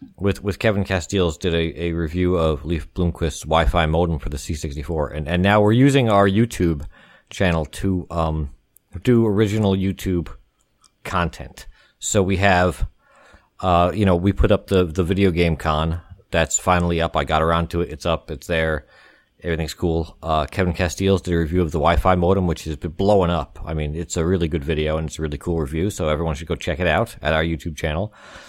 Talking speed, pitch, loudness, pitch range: 205 wpm, 85 Hz, -21 LUFS, 80-95 Hz